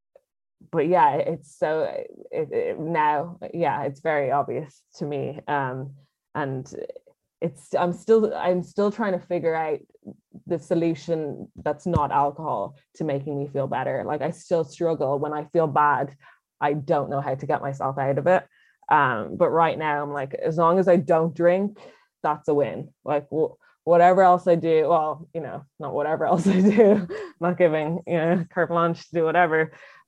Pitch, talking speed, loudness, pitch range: 165 Hz, 180 wpm, -23 LUFS, 150-185 Hz